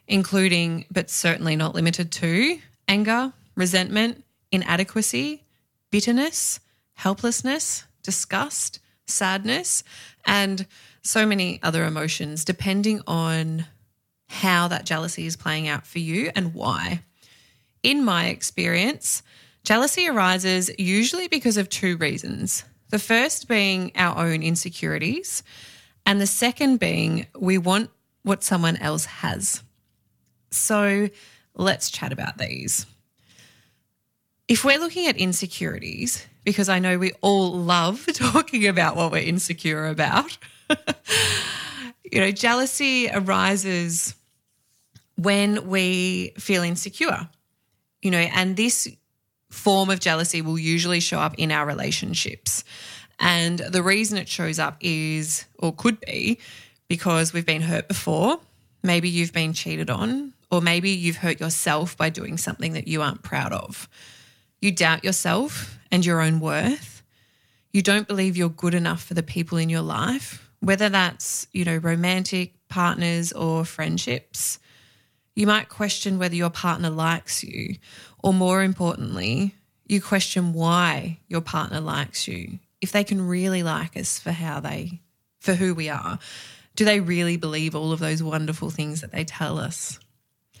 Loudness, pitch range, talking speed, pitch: -23 LUFS, 165-200 Hz, 135 wpm, 180 Hz